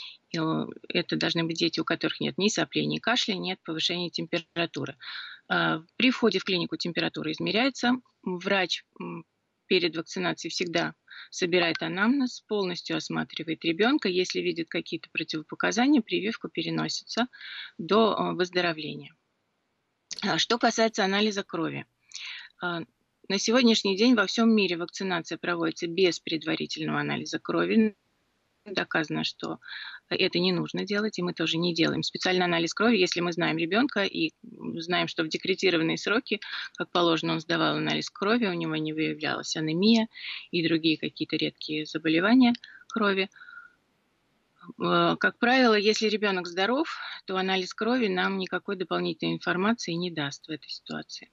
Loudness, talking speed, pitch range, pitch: -27 LUFS, 130 wpm, 165-210 Hz, 180 Hz